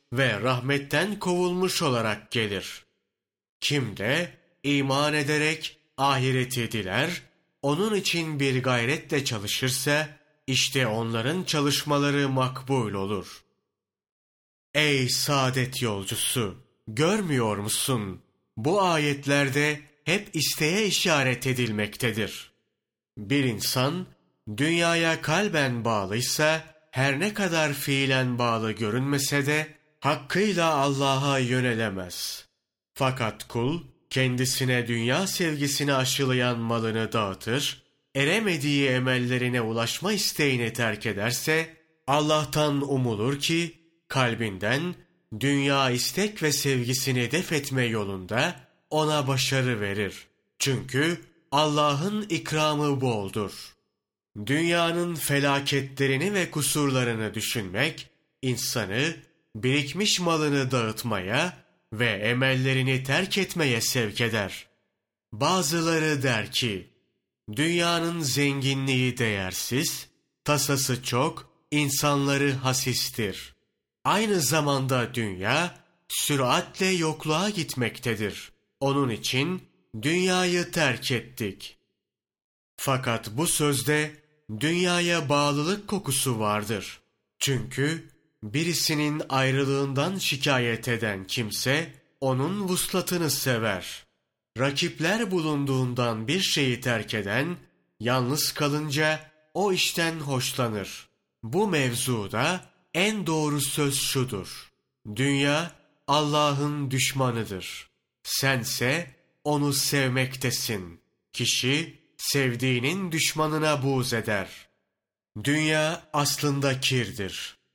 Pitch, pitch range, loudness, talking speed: 140 Hz, 120-155 Hz, -25 LUFS, 85 wpm